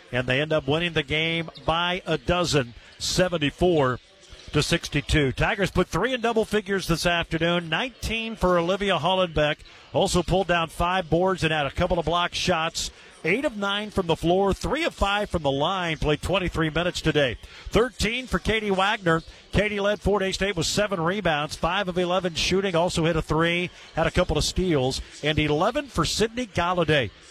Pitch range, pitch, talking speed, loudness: 160-195 Hz, 175 Hz, 180 wpm, -24 LUFS